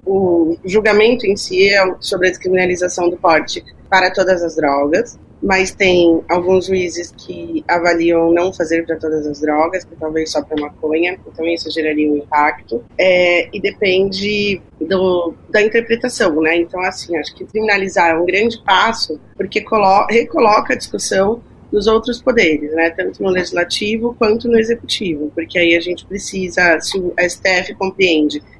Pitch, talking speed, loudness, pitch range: 180 Hz, 160 wpm, -15 LUFS, 165-195 Hz